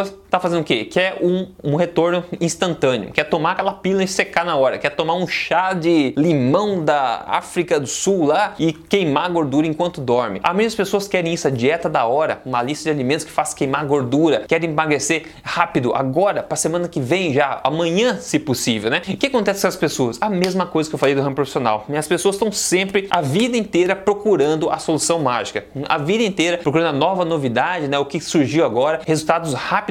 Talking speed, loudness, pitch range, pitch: 205 wpm, -19 LUFS, 150-190 Hz, 165 Hz